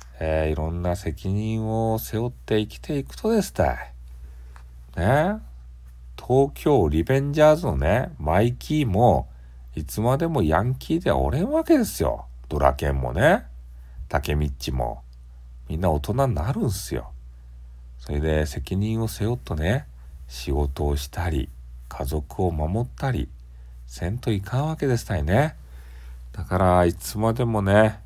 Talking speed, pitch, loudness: 270 characters per minute, 80 Hz, -24 LUFS